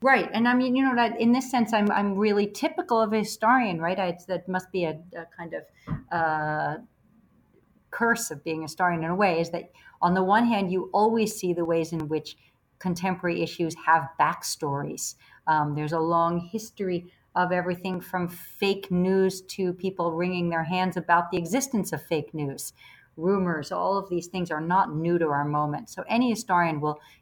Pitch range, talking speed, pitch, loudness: 165-205 Hz, 195 wpm, 180 Hz, -26 LUFS